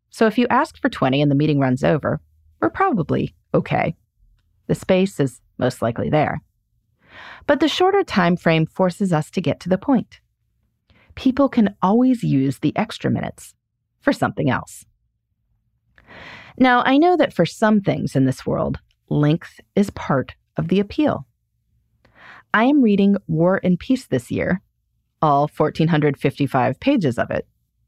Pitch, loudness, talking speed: 180 Hz, -19 LUFS, 155 wpm